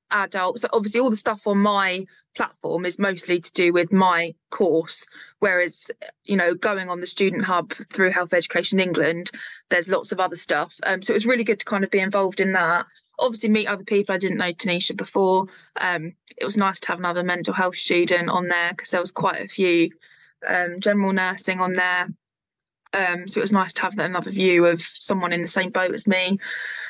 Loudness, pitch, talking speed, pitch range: -21 LUFS, 185 Hz, 210 wpm, 175-200 Hz